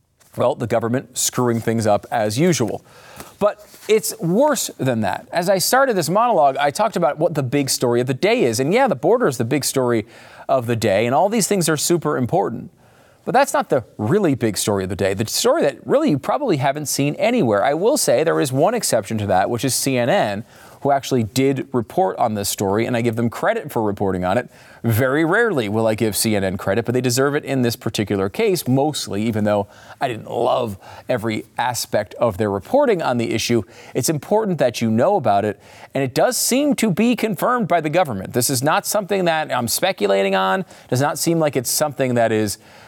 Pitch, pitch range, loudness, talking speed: 125 Hz, 110-155 Hz, -19 LUFS, 220 wpm